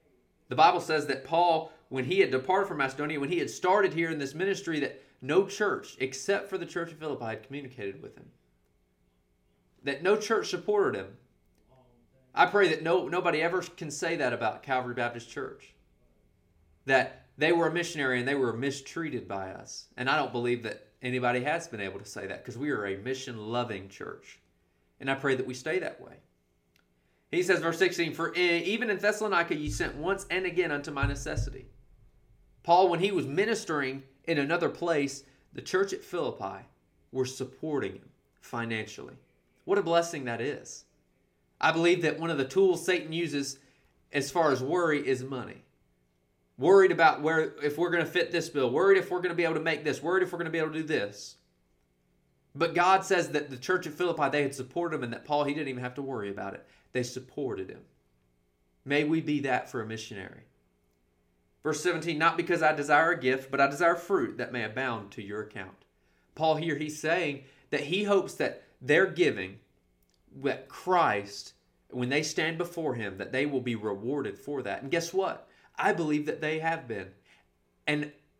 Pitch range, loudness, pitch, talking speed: 115-170 Hz, -29 LUFS, 140 Hz, 195 wpm